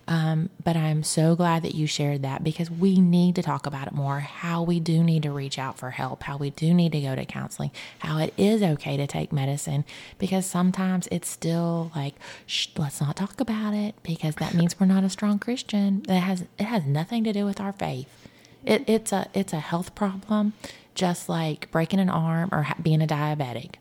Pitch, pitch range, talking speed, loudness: 165 Hz, 150-190 Hz, 215 wpm, -26 LUFS